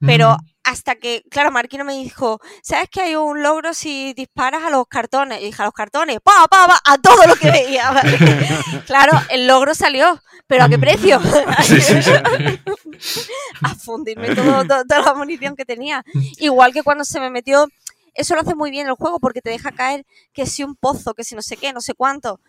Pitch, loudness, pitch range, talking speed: 270 Hz, -14 LUFS, 240-295 Hz, 205 wpm